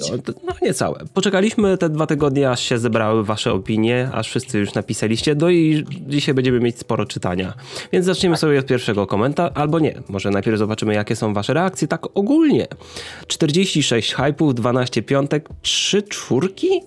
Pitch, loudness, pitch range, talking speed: 135 Hz, -19 LUFS, 115-165 Hz, 165 wpm